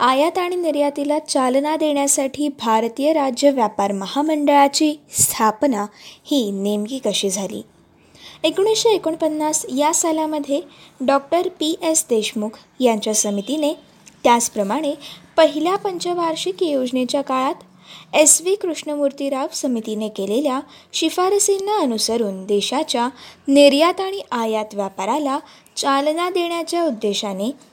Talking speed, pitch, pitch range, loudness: 95 wpm, 285 Hz, 230-315 Hz, -19 LUFS